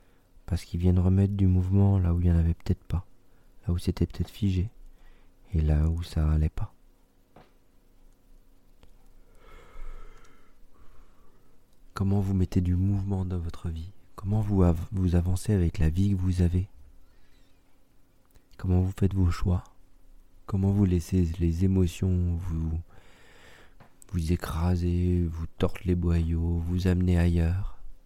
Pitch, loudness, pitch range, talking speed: 90 Hz, -27 LUFS, 85-95 Hz, 140 wpm